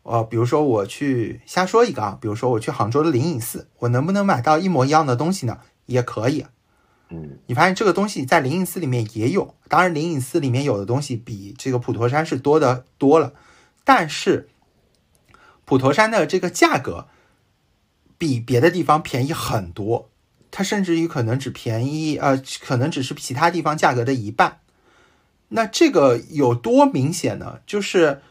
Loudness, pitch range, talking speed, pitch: -20 LUFS, 120-170 Hz, 275 characters per minute, 140 Hz